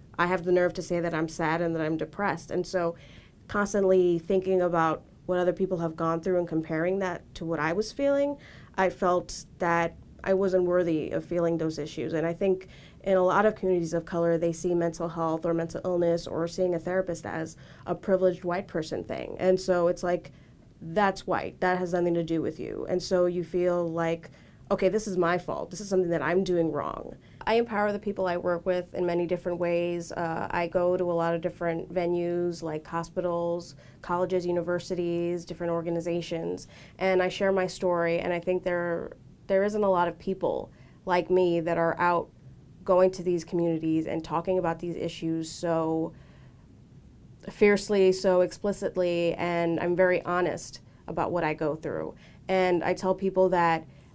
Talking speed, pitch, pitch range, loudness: 190 wpm, 175 Hz, 165-185 Hz, -28 LUFS